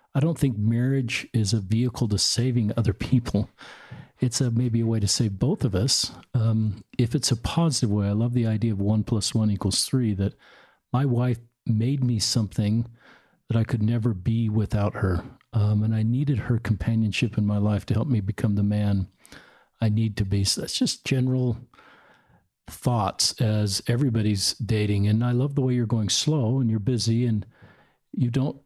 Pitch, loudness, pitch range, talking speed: 115 Hz, -24 LUFS, 105-125 Hz, 190 wpm